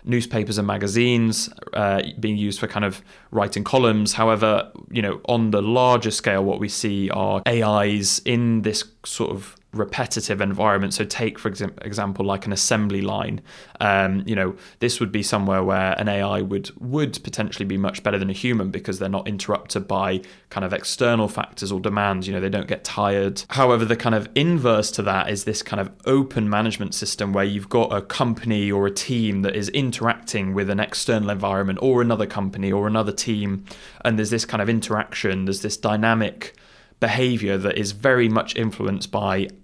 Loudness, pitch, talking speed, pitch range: -22 LUFS, 105 Hz, 190 wpm, 100-115 Hz